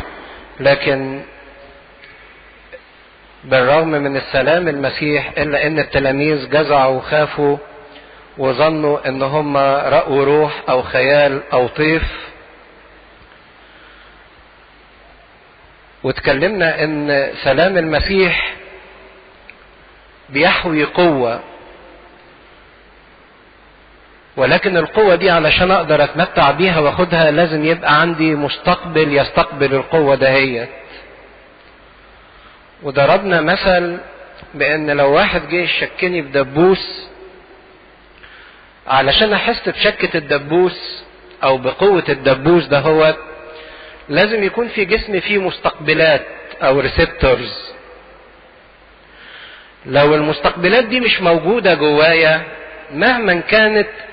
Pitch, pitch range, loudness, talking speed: 155 Hz, 140-175 Hz, -14 LUFS, 80 wpm